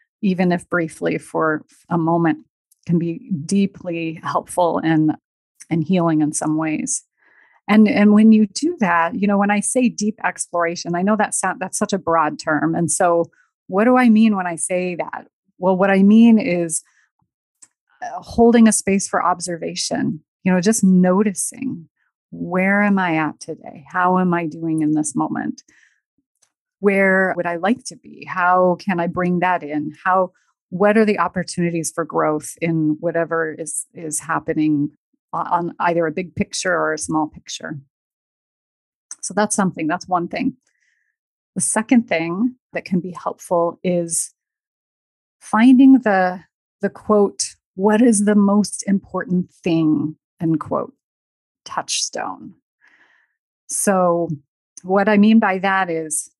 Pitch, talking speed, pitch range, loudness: 180 Hz, 150 wpm, 165-210 Hz, -18 LUFS